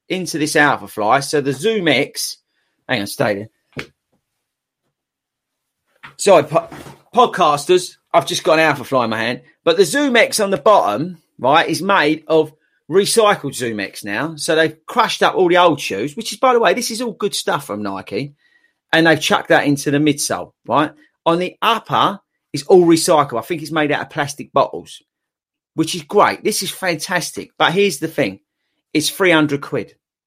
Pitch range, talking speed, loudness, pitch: 145-195 Hz, 185 wpm, -16 LUFS, 160 Hz